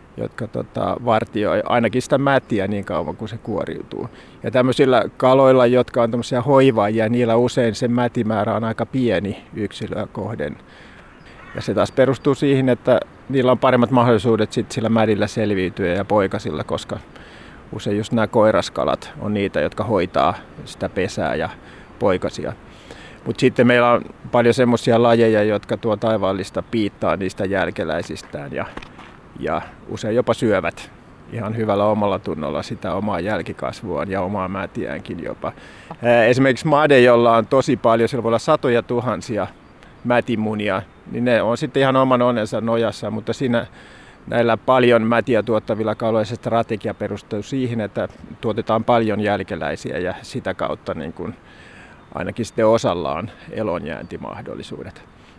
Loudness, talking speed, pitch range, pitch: -19 LUFS, 140 wpm, 105-125 Hz, 115 Hz